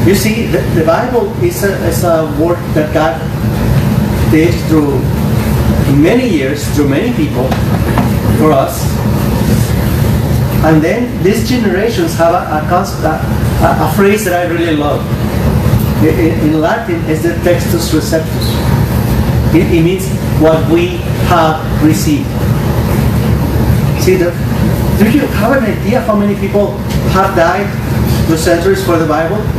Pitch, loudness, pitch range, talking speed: 160 Hz, -11 LUFS, 130-175 Hz, 135 wpm